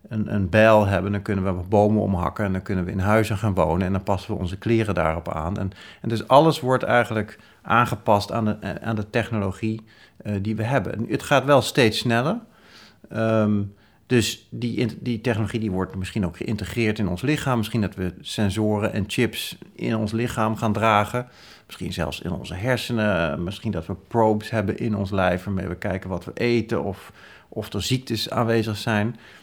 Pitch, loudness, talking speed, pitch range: 110 Hz, -23 LUFS, 195 wpm, 100-115 Hz